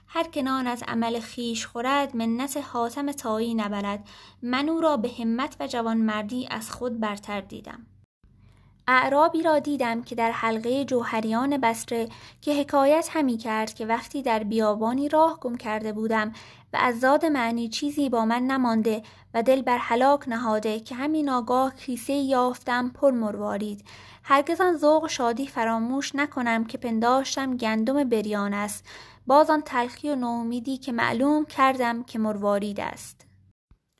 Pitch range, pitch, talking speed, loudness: 225-275 Hz, 245 Hz, 145 wpm, -25 LUFS